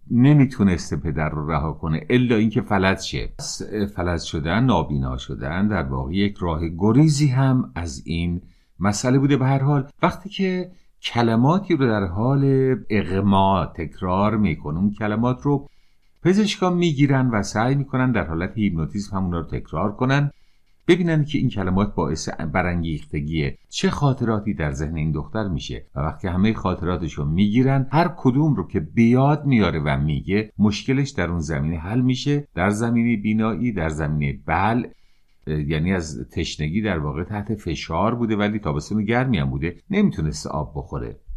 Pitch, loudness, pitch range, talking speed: 105 Hz, -22 LUFS, 80-130 Hz, 150 wpm